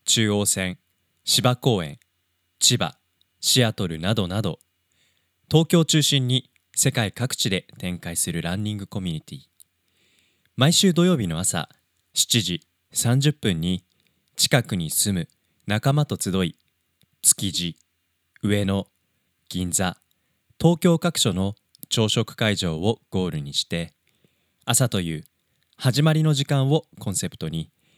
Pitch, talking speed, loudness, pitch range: 95 Hz, 215 characters per minute, -22 LUFS, 85-125 Hz